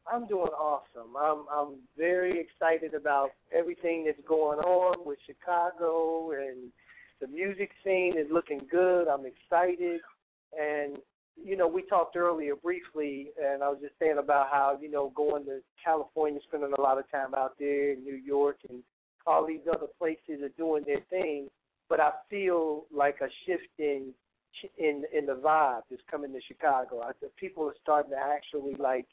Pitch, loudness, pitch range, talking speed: 150 Hz, -30 LUFS, 140-170 Hz, 170 wpm